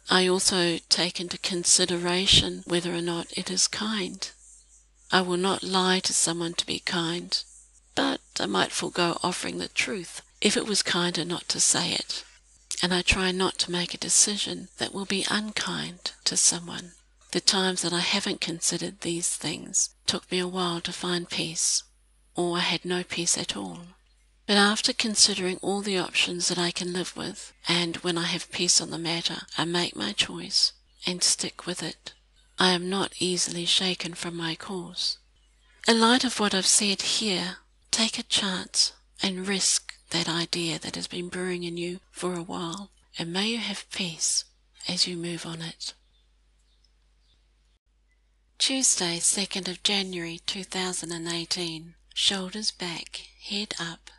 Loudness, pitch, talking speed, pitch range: -25 LUFS, 175 Hz, 170 wpm, 170-190 Hz